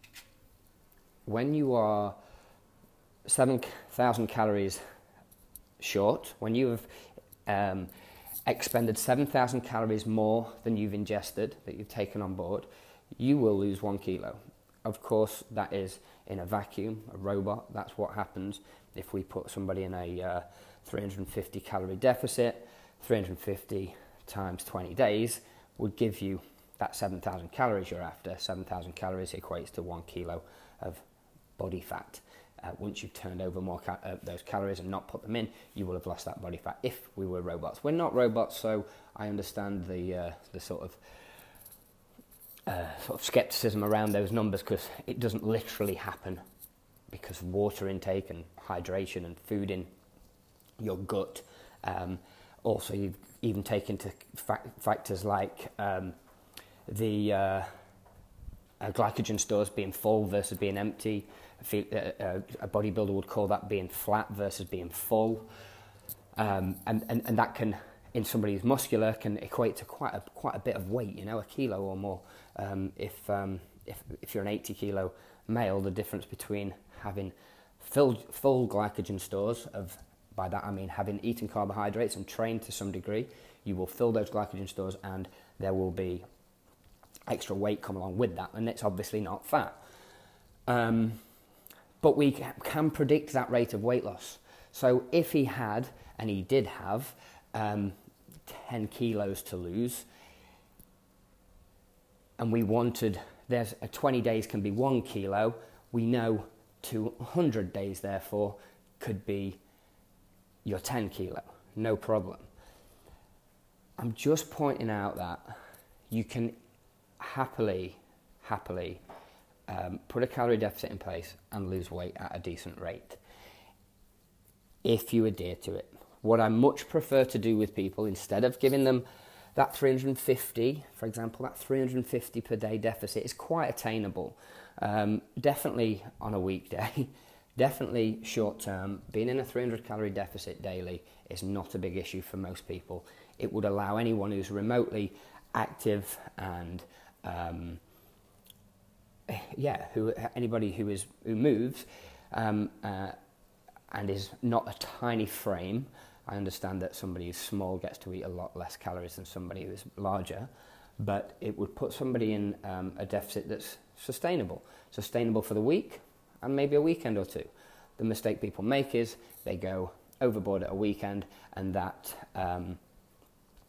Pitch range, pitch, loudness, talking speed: 95-115 Hz, 100 Hz, -33 LUFS, 150 wpm